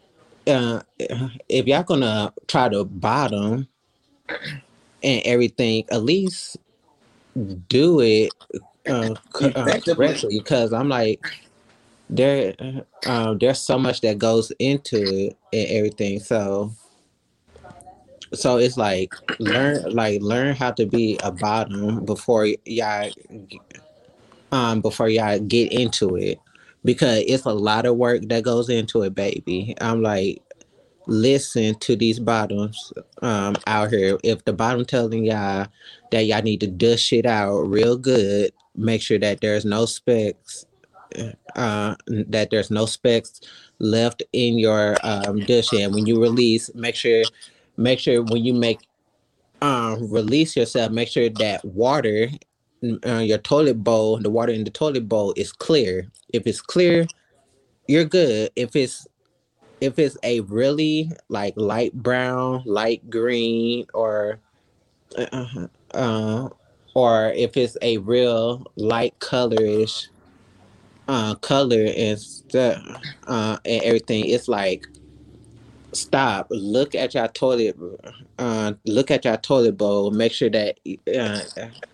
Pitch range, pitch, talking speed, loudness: 105-125 Hz, 115 Hz, 135 wpm, -21 LUFS